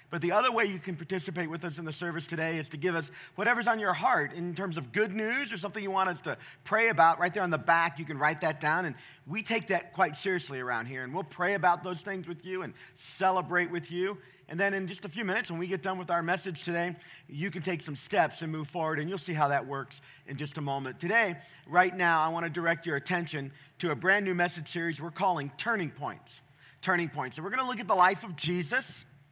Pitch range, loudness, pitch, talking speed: 155-190 Hz, -30 LUFS, 175 Hz, 260 wpm